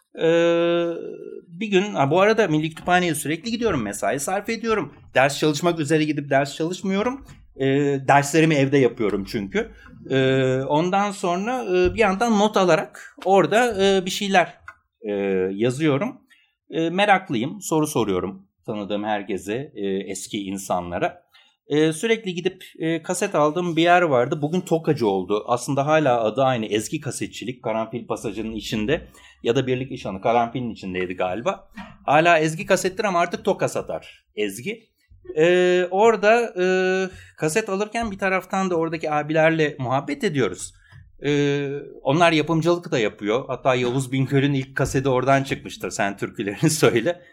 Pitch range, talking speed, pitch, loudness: 130-185 Hz, 130 wpm, 155 Hz, -22 LUFS